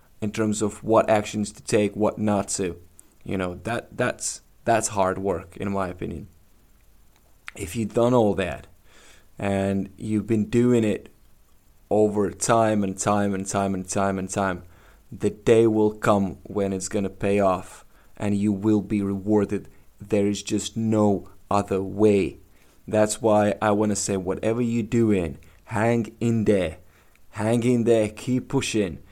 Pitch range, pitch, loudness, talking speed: 95-110 Hz, 105 Hz, -24 LUFS, 155 wpm